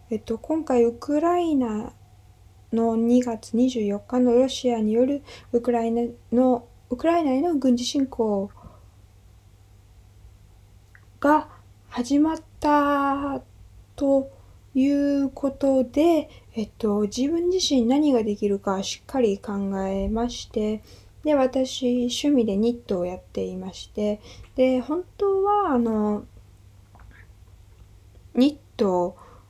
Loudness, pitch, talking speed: -24 LUFS, 235 Hz, 195 characters per minute